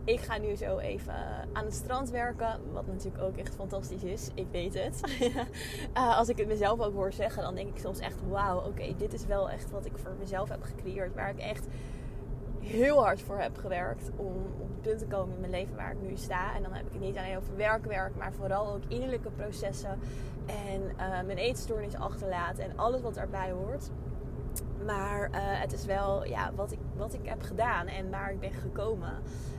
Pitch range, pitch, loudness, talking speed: 195-255 Hz, 230 Hz, -34 LUFS, 215 wpm